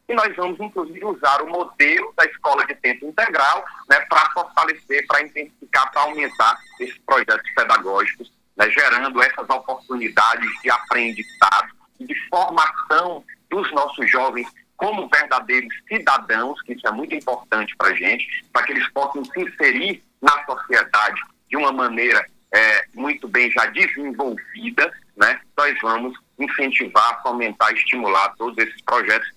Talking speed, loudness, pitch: 140 wpm, -18 LUFS, 155 Hz